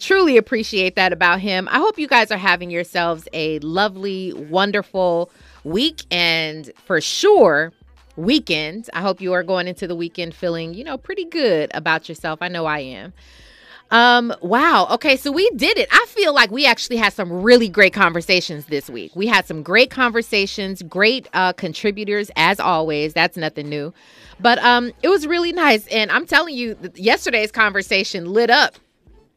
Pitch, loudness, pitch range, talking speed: 195 Hz, -17 LUFS, 175-240 Hz, 175 wpm